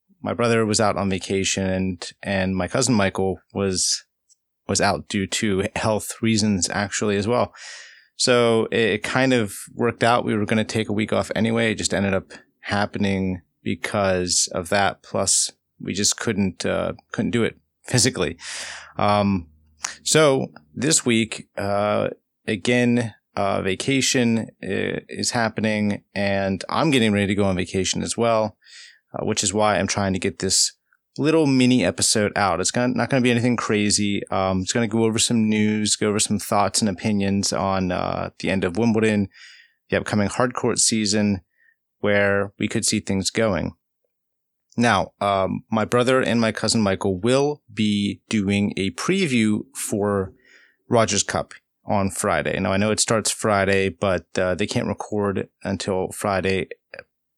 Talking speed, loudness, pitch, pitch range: 160 wpm, -21 LUFS, 105 Hz, 95-115 Hz